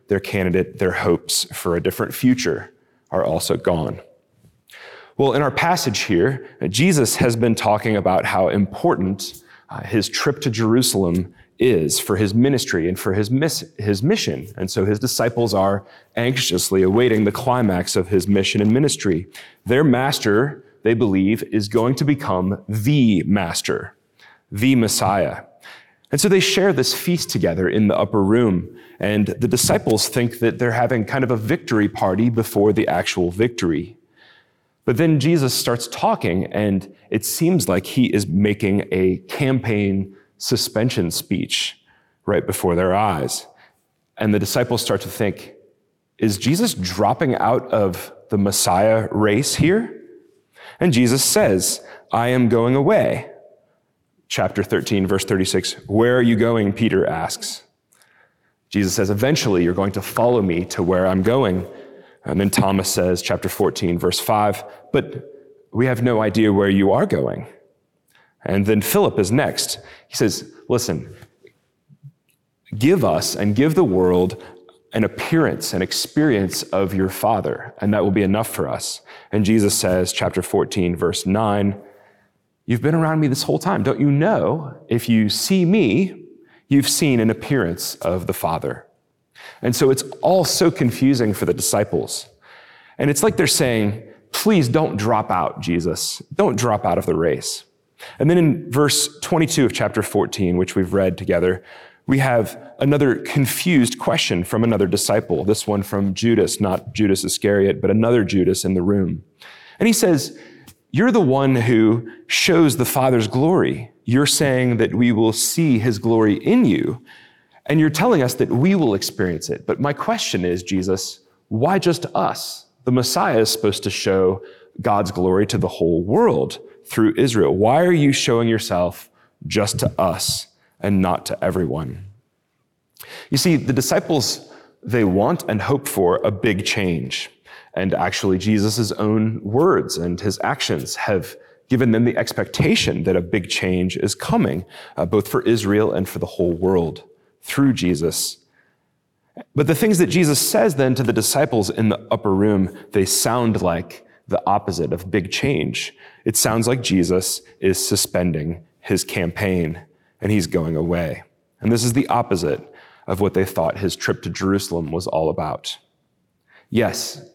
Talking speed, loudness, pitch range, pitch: 160 wpm, -19 LUFS, 95-130 Hz, 110 Hz